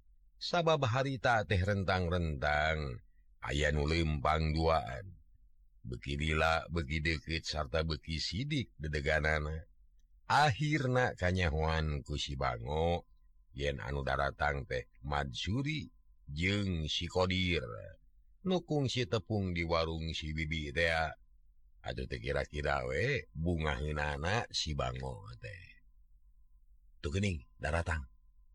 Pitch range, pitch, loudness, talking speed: 75-90 Hz, 80 Hz, -34 LUFS, 85 wpm